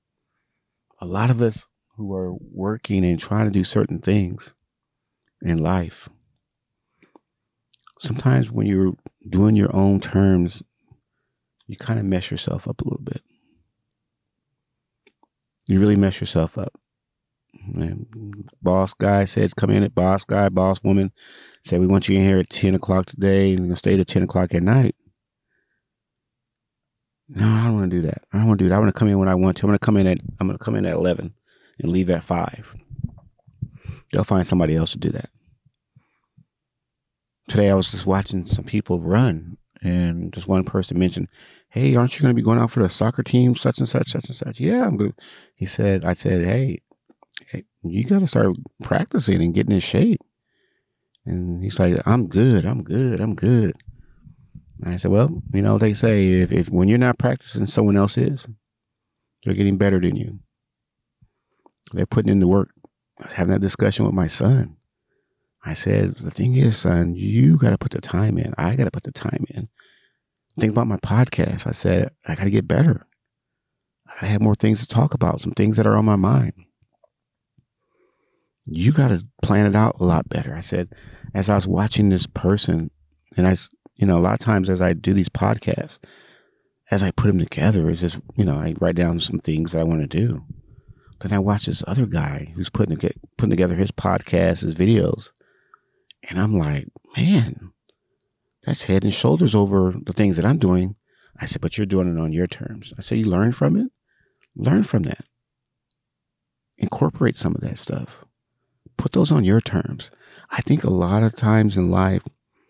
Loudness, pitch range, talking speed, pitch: -20 LUFS, 95-115 Hz, 195 wpm, 100 Hz